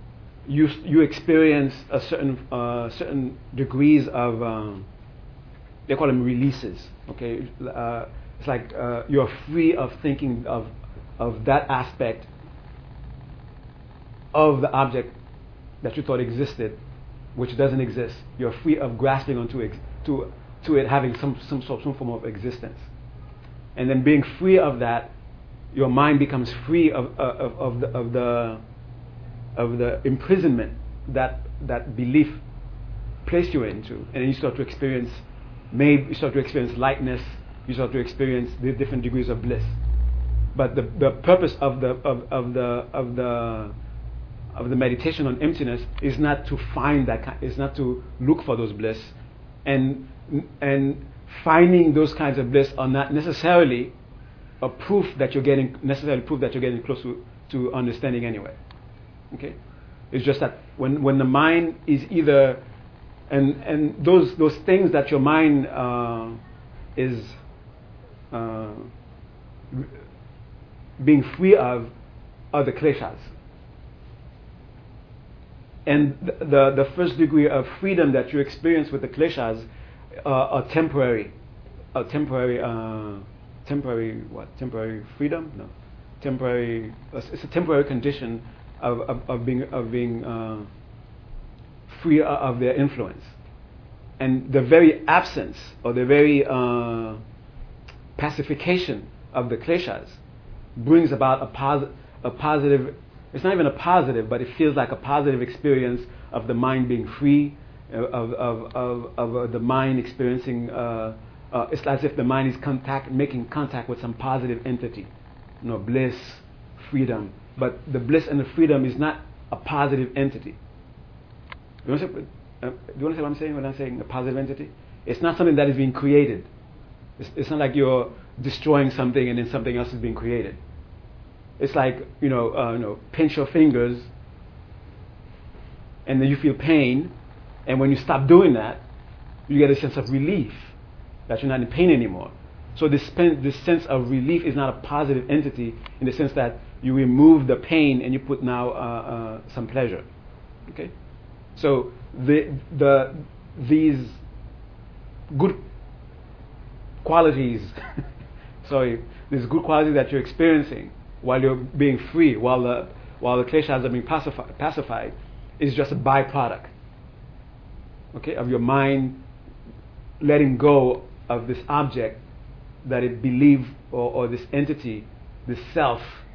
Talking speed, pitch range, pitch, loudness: 150 wpm, 120-145 Hz, 130 Hz, -22 LUFS